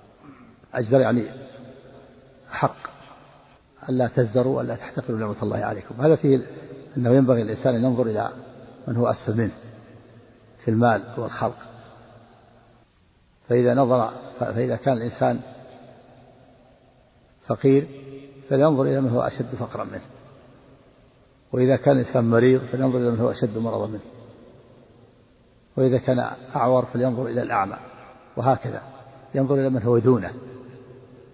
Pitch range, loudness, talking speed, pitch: 120-130 Hz, -22 LUFS, 115 wpm, 125 Hz